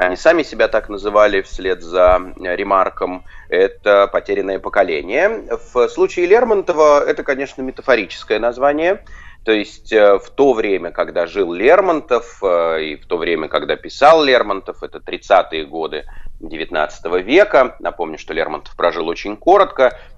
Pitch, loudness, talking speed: 110 Hz, -16 LUFS, 130 wpm